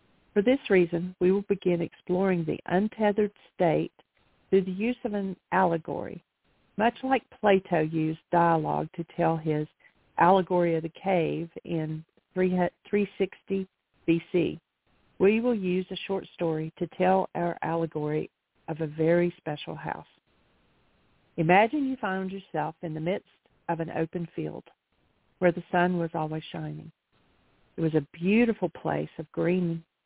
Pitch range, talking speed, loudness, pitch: 165-195 Hz, 140 wpm, -28 LUFS, 175 Hz